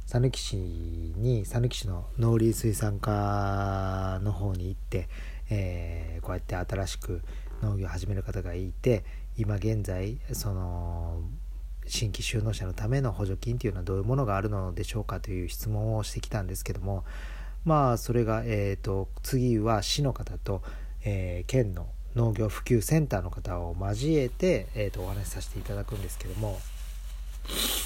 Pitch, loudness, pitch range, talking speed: 100 Hz, -30 LUFS, 90-110 Hz, 300 characters per minute